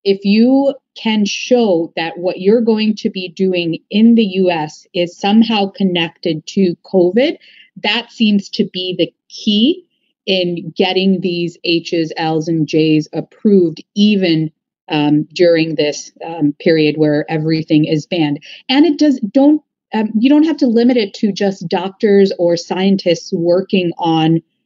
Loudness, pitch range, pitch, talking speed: -14 LUFS, 165-215 Hz, 190 Hz, 150 wpm